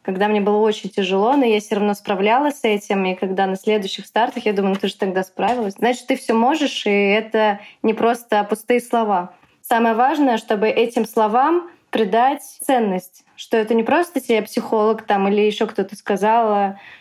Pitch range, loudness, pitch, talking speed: 205-240 Hz, -19 LUFS, 220 Hz, 185 wpm